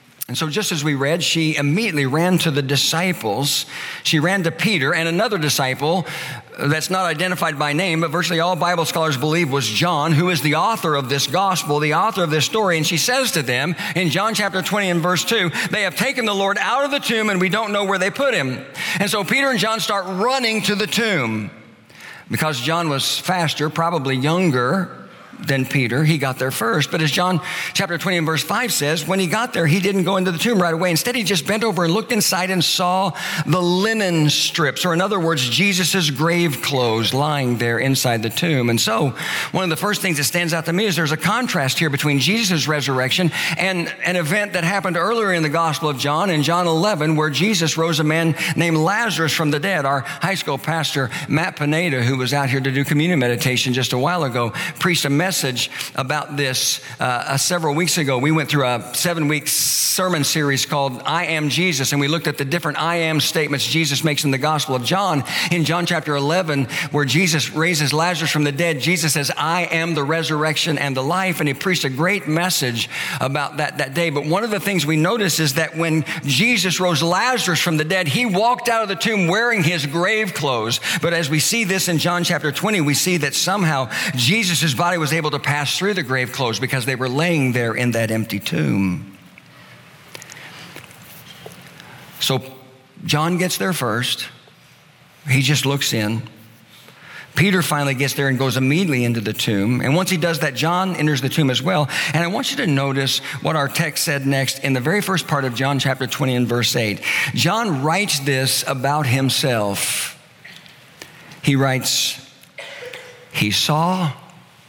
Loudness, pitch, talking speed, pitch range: -18 LUFS, 160 Hz, 205 wpm, 140-180 Hz